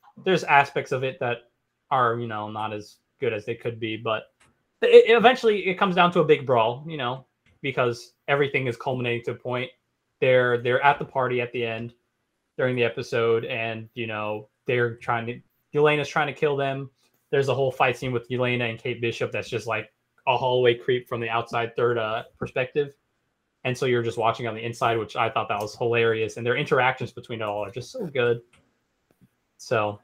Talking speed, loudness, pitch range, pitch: 210 wpm, -24 LUFS, 115-135 Hz, 120 Hz